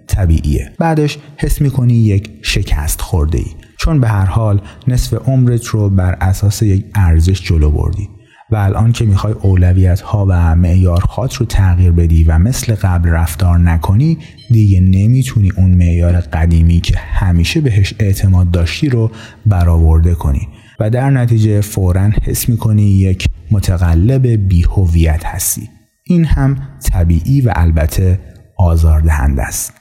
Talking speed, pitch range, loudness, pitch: 135 wpm, 85-115 Hz, -13 LUFS, 100 Hz